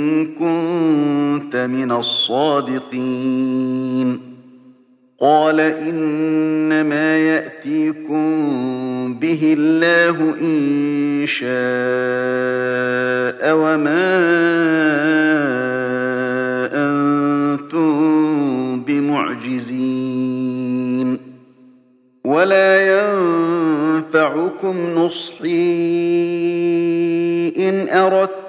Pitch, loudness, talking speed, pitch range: 150 Hz, -17 LUFS, 40 wpm, 130-165 Hz